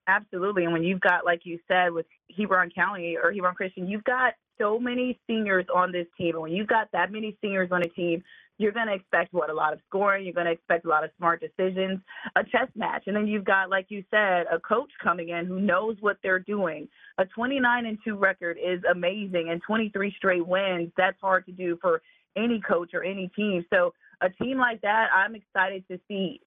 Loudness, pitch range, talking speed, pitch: -26 LUFS, 175-210 Hz, 225 wpm, 190 Hz